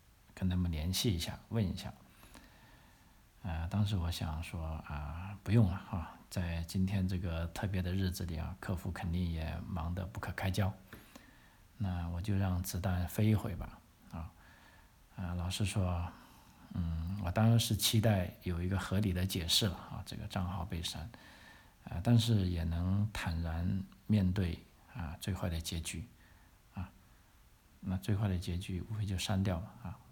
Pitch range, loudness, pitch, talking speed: 85-100 Hz, -36 LUFS, 95 Hz, 225 characters per minute